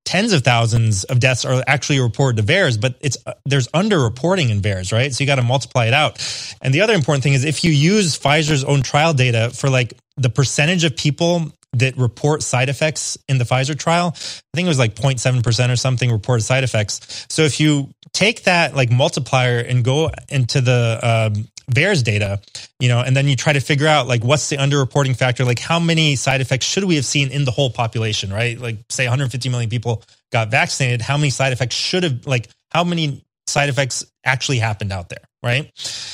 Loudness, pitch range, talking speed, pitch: -17 LUFS, 120-145 Hz, 215 wpm, 130 Hz